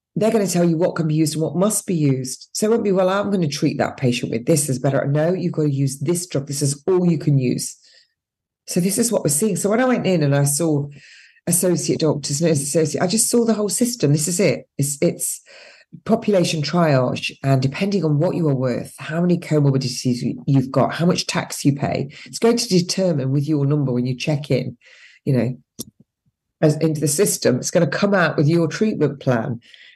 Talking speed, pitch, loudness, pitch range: 230 wpm, 160 Hz, -19 LUFS, 145-190 Hz